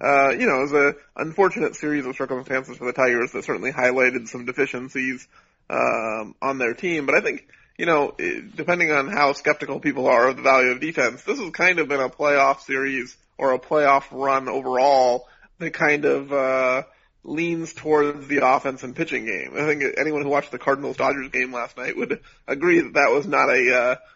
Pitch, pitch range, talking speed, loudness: 135 Hz, 130-150 Hz, 200 wpm, -21 LUFS